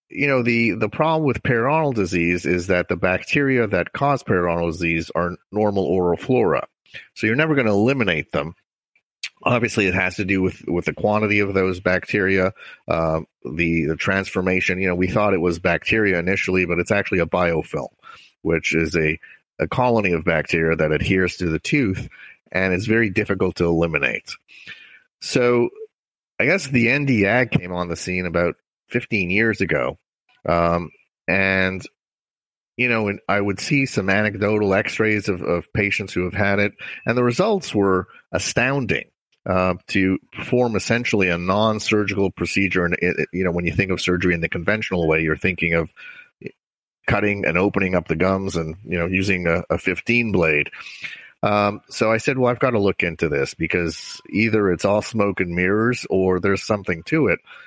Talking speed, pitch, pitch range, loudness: 180 wpm, 95 Hz, 90-110 Hz, -20 LUFS